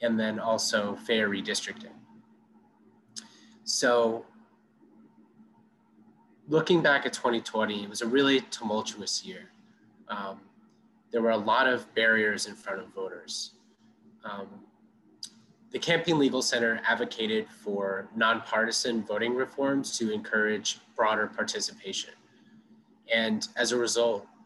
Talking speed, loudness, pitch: 110 wpm, -28 LUFS, 130 Hz